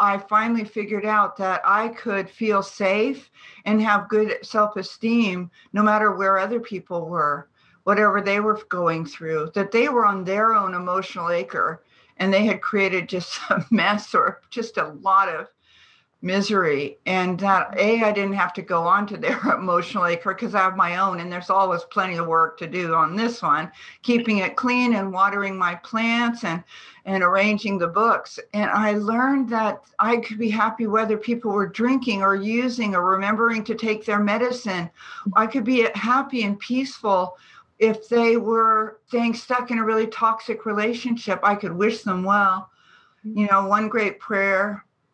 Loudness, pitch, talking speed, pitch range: -22 LUFS, 205 Hz, 180 wpm, 190-225 Hz